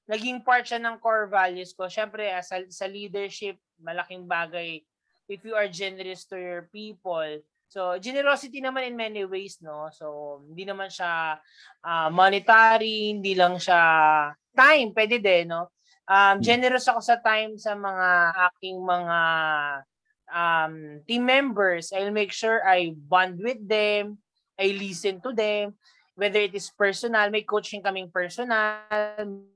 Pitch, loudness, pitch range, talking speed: 195 Hz, -23 LUFS, 175-215 Hz, 145 wpm